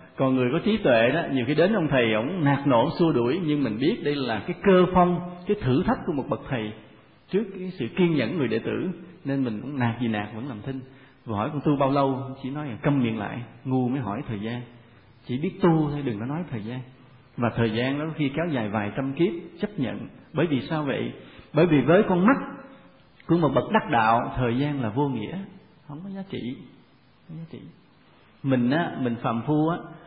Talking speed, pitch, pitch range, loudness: 235 wpm, 135 Hz, 120-165 Hz, -25 LUFS